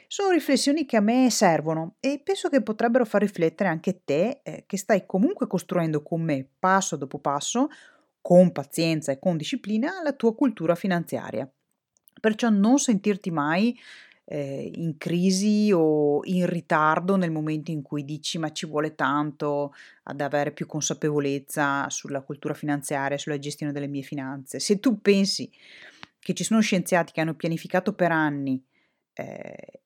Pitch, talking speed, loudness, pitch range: 170 Hz, 155 wpm, -25 LUFS, 150-210 Hz